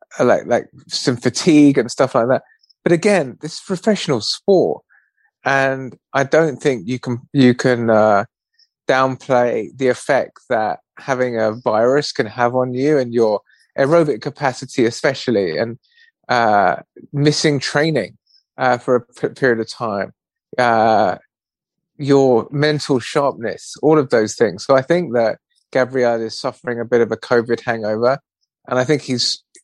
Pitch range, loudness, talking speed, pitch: 125-150 Hz, -17 LUFS, 150 wpm, 135 Hz